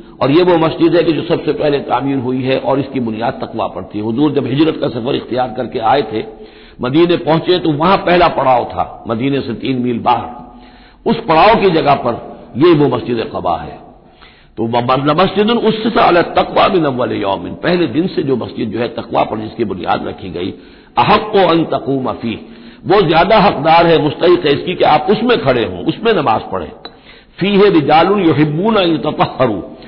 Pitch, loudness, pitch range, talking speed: 150 Hz, -13 LUFS, 125-175 Hz, 185 wpm